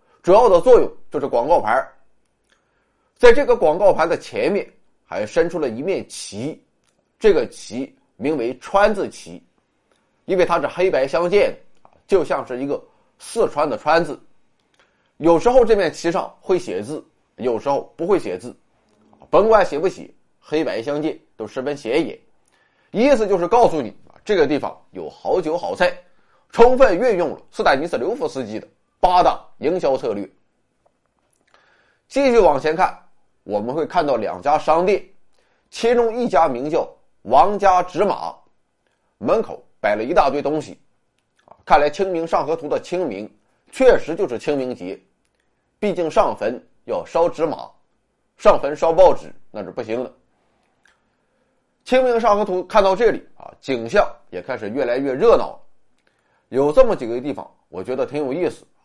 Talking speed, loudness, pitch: 225 characters per minute, -19 LUFS, 215 Hz